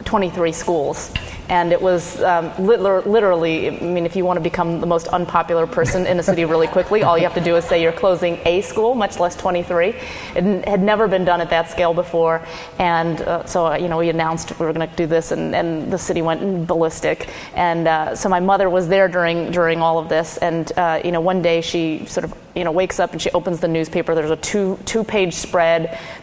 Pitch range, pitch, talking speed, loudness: 165-185 Hz, 175 Hz, 235 wpm, -18 LUFS